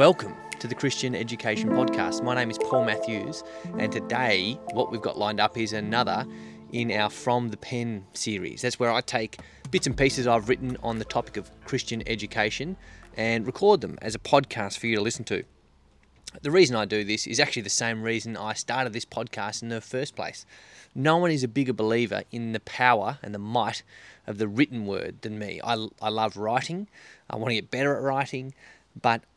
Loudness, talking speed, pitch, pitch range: -27 LUFS, 205 wpm, 115 Hz, 110-130 Hz